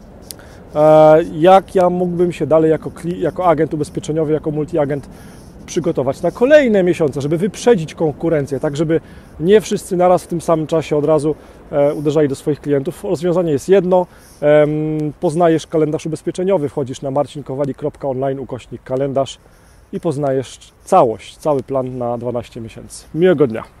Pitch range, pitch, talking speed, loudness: 145-175 Hz, 155 Hz, 130 wpm, -16 LUFS